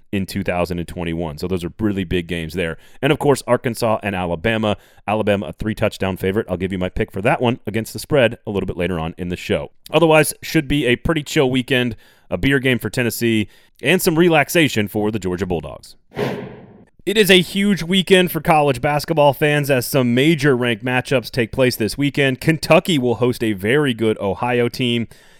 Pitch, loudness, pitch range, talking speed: 120 Hz, -18 LUFS, 100-145 Hz, 200 wpm